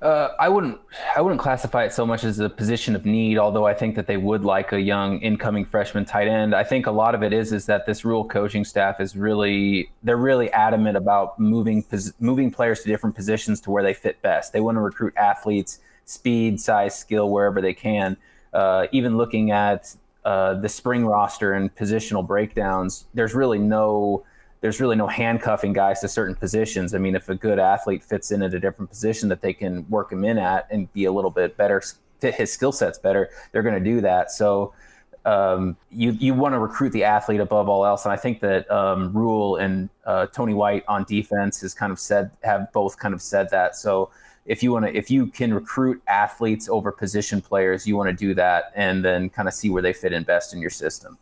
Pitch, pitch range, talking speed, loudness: 105 Hz, 100-110 Hz, 225 wpm, -22 LUFS